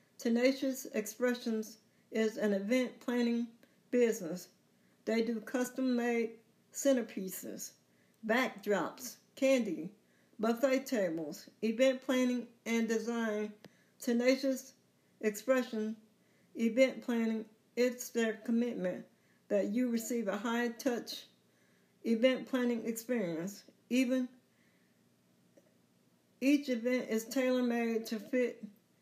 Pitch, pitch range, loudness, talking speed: 235 Hz, 215-255 Hz, -34 LUFS, 90 wpm